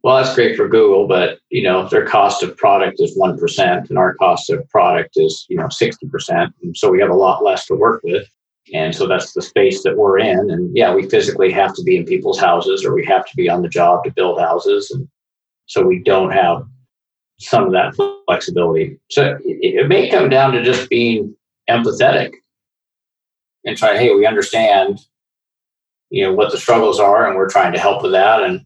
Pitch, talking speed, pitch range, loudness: 395 Hz, 210 wpm, 345-420 Hz, -14 LUFS